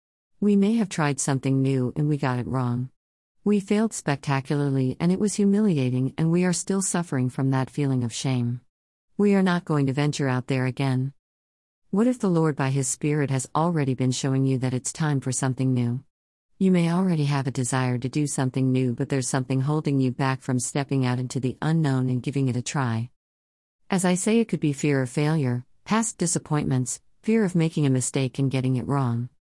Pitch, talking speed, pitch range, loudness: 135 Hz, 205 wpm, 130-160 Hz, -24 LUFS